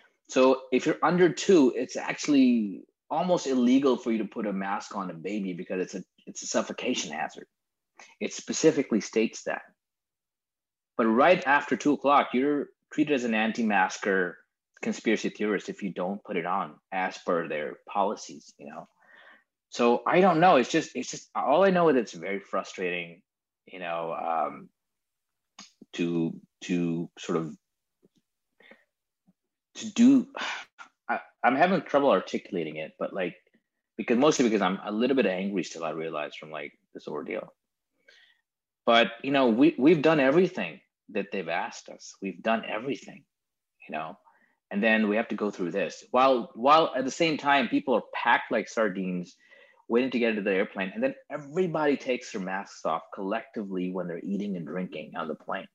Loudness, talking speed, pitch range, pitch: -27 LUFS, 170 wpm, 100-160 Hz, 125 Hz